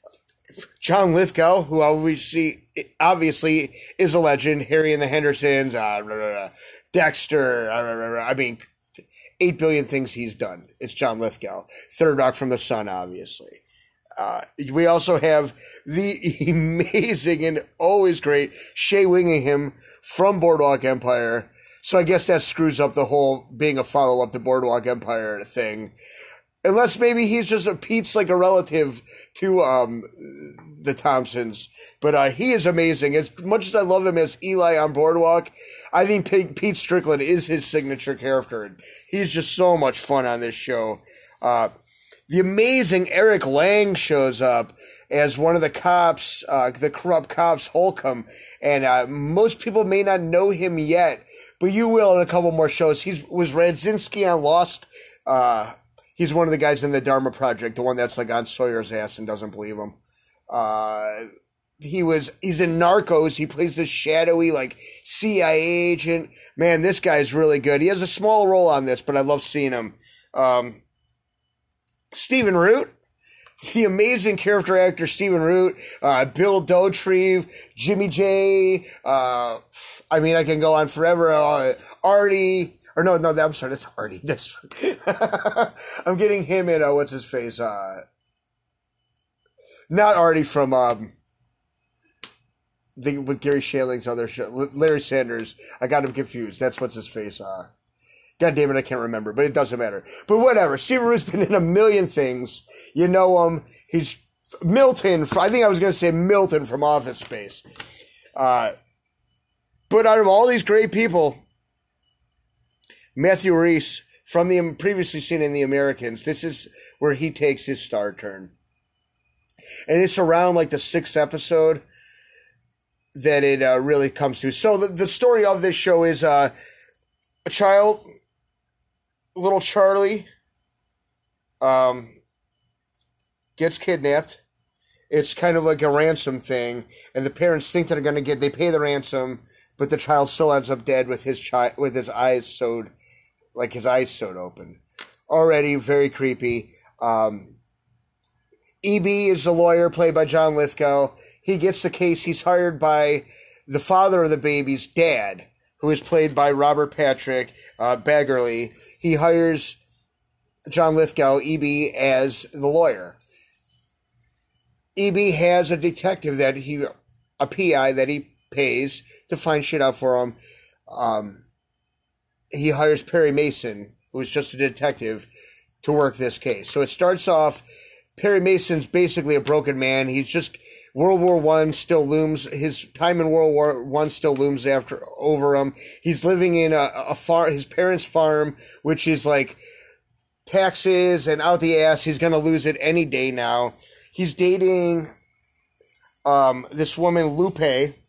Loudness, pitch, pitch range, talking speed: -20 LUFS, 155 Hz, 130-180 Hz, 160 wpm